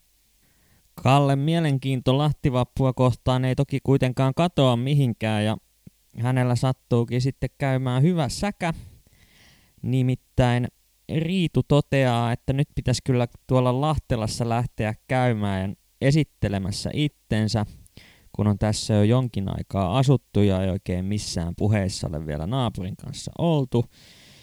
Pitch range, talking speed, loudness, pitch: 105-135 Hz, 115 wpm, -24 LUFS, 125 Hz